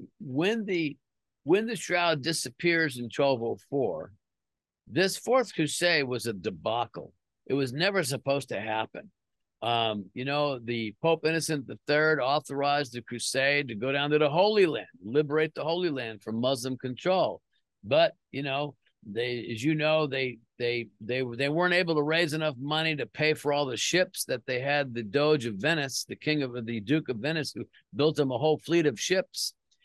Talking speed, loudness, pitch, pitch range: 180 wpm, -28 LUFS, 145 Hz, 120-160 Hz